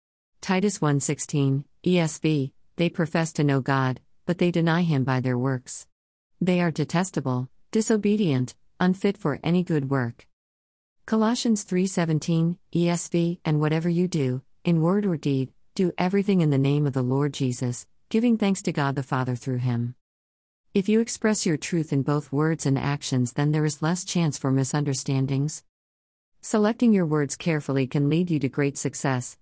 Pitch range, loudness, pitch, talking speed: 135-175 Hz, -25 LUFS, 150 Hz, 160 wpm